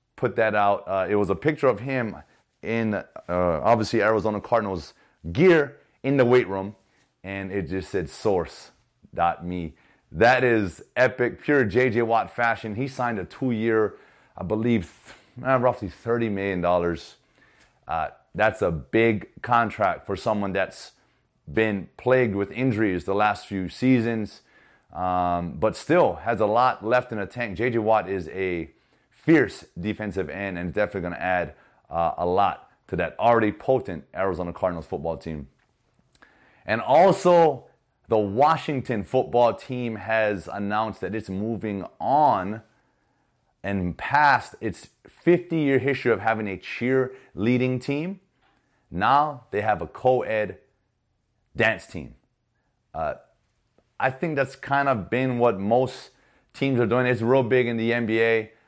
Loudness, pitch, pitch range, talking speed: -24 LUFS, 110 Hz, 100-125 Hz, 145 wpm